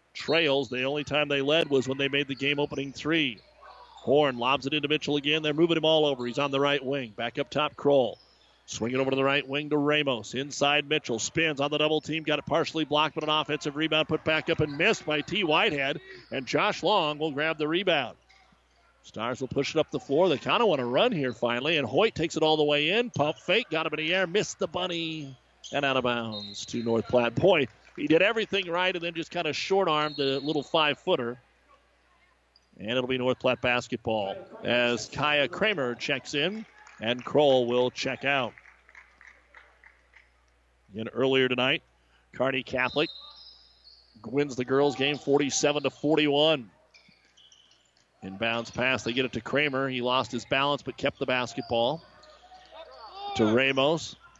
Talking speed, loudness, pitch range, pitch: 190 wpm, -26 LUFS, 125-155 Hz, 140 Hz